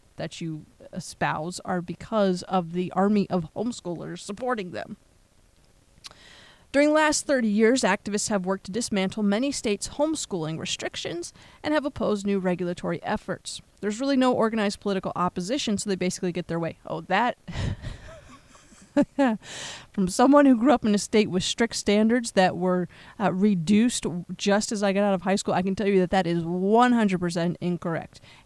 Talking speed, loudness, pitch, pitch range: 165 wpm, -25 LUFS, 200 Hz, 180-225 Hz